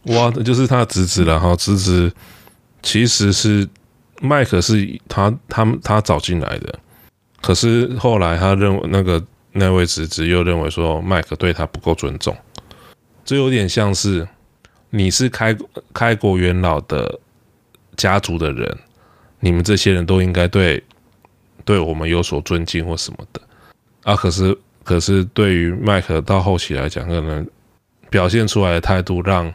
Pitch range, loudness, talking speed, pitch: 85-105 Hz, -17 LUFS, 225 characters per minute, 95 Hz